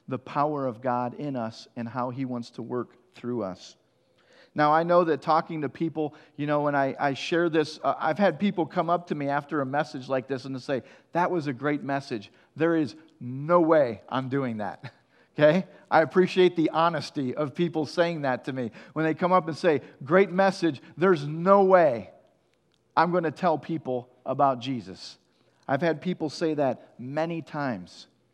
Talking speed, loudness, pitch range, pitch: 195 wpm, -26 LUFS, 130-170 Hz, 150 Hz